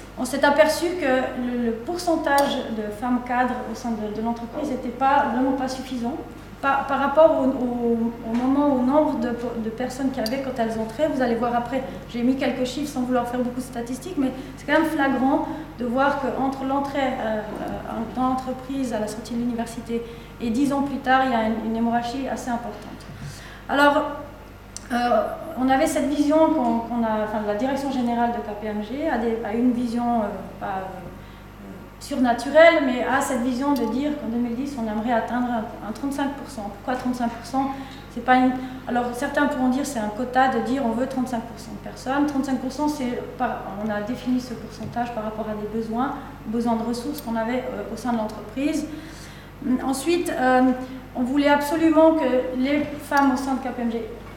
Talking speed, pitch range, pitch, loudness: 190 wpm, 235-275 Hz, 255 Hz, -23 LUFS